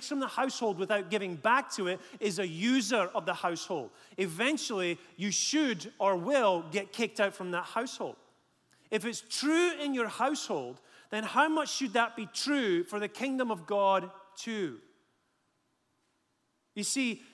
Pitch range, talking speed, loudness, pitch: 195-265 Hz, 160 wpm, -31 LUFS, 220 Hz